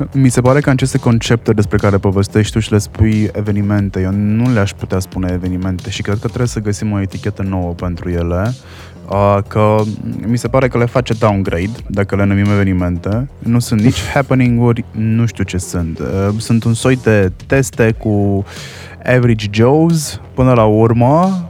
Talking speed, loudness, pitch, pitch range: 175 wpm, -14 LUFS, 105 Hz, 95-120 Hz